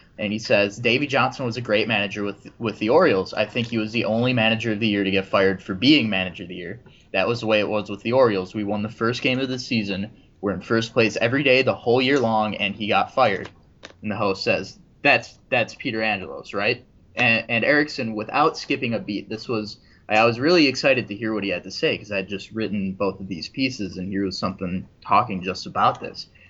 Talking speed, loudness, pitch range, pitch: 245 wpm, -22 LUFS, 100-115 Hz, 110 Hz